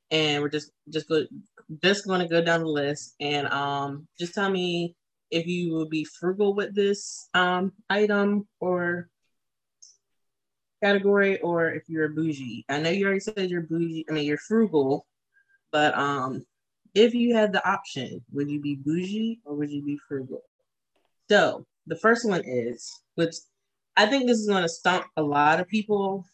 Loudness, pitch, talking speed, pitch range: -25 LUFS, 170 Hz, 170 wpm, 150-200 Hz